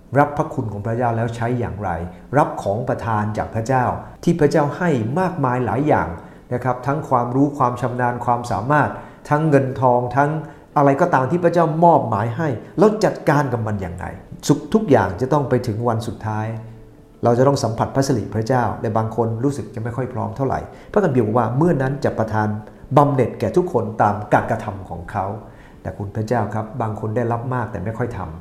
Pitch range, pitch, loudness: 110-140 Hz, 125 Hz, -20 LUFS